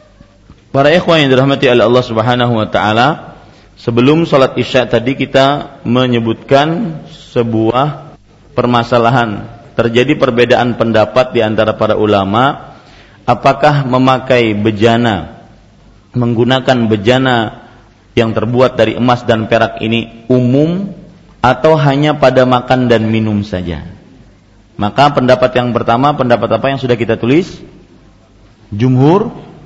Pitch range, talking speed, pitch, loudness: 110-130 Hz, 110 wpm, 120 Hz, -11 LUFS